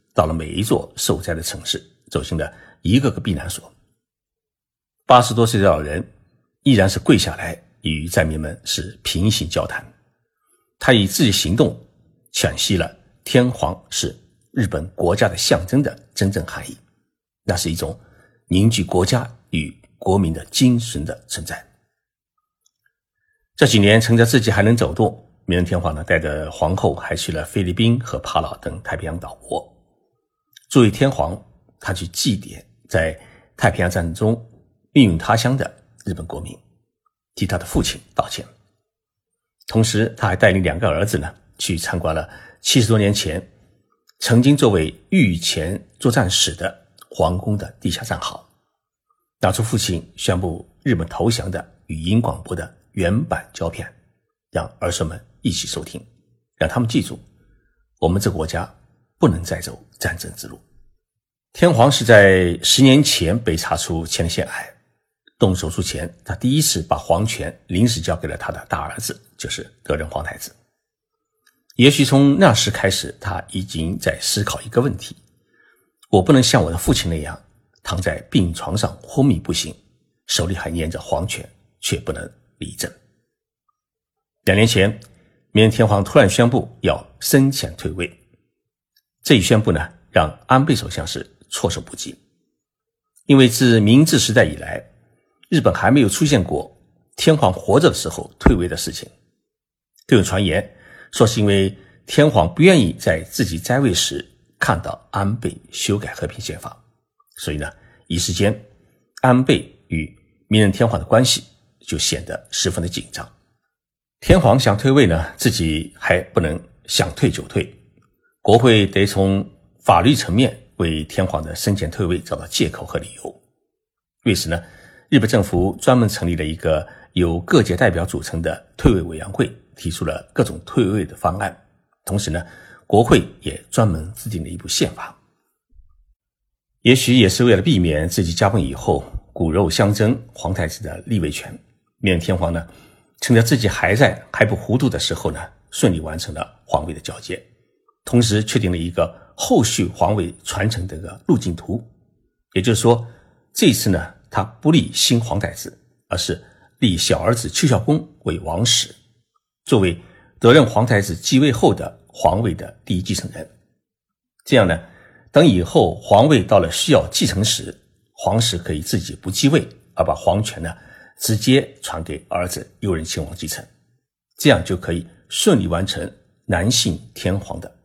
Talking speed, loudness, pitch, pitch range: 235 characters per minute, -18 LUFS, 100 Hz, 85-120 Hz